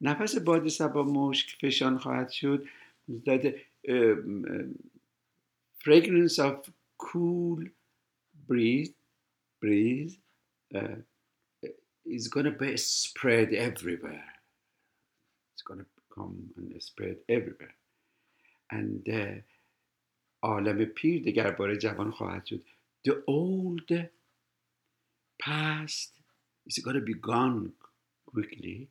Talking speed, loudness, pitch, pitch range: 90 wpm, -30 LUFS, 140 Hz, 115-165 Hz